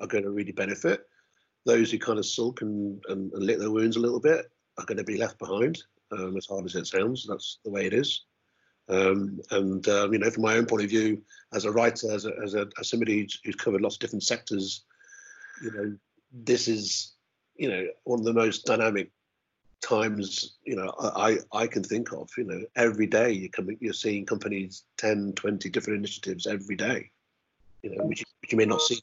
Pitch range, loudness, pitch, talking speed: 100-115 Hz, -28 LUFS, 105 Hz, 220 wpm